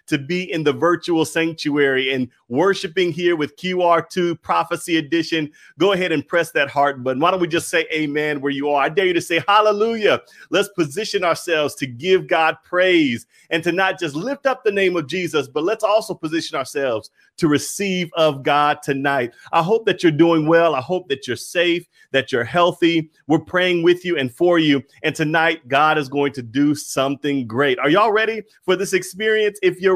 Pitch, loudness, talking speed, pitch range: 165 Hz, -19 LUFS, 200 wpm, 150-185 Hz